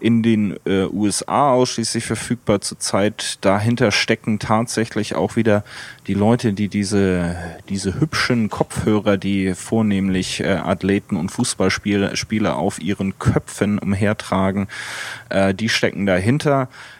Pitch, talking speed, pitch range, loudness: 105 Hz, 120 wpm, 95-115 Hz, -19 LUFS